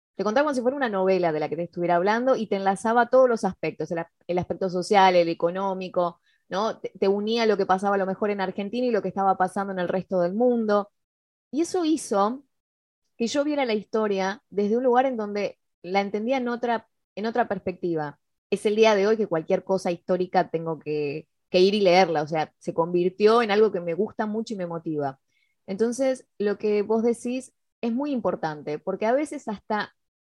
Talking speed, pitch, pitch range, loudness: 215 wpm, 200 Hz, 180-225 Hz, -25 LUFS